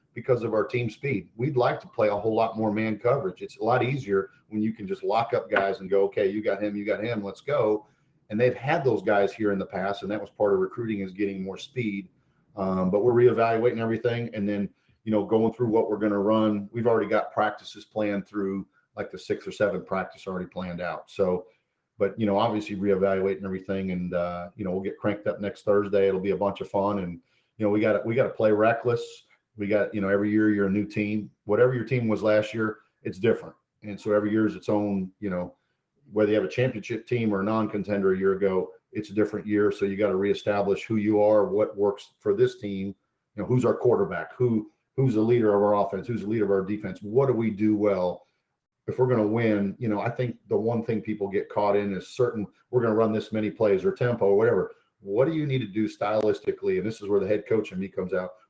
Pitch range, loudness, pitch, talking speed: 100-115 Hz, -26 LUFS, 105 Hz, 255 wpm